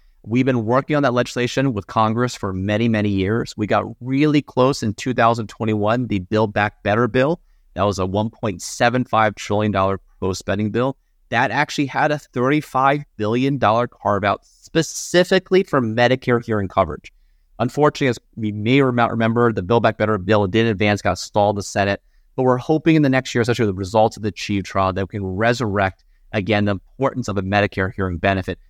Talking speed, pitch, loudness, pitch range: 180 wpm, 110 Hz, -19 LUFS, 100-130 Hz